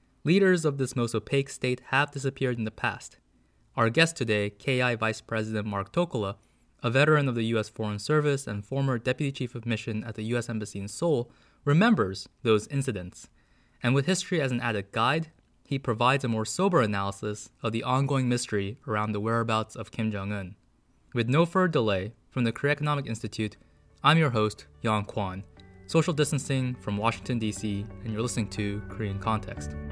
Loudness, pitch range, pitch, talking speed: -28 LUFS, 105-135 Hz, 115 Hz, 180 wpm